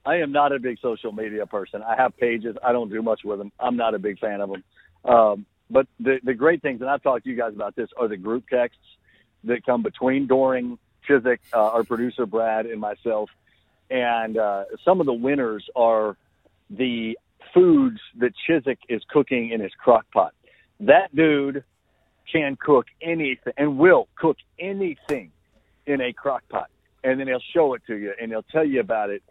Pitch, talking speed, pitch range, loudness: 120 Hz, 195 wpm, 110-140 Hz, -22 LUFS